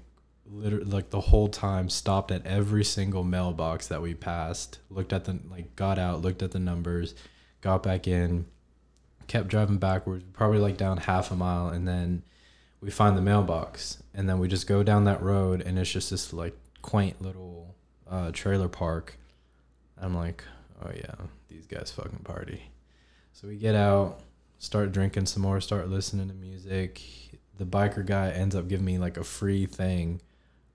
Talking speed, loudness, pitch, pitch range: 175 wpm, -29 LUFS, 90 Hz, 85-100 Hz